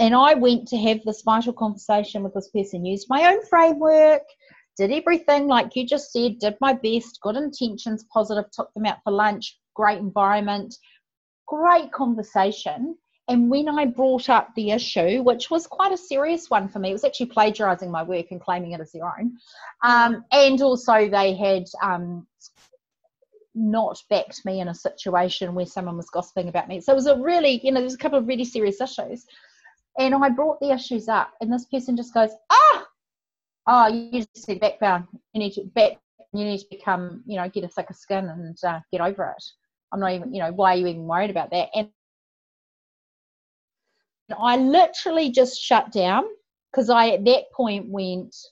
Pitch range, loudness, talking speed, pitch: 195-270 Hz, -21 LUFS, 195 wpm, 225 Hz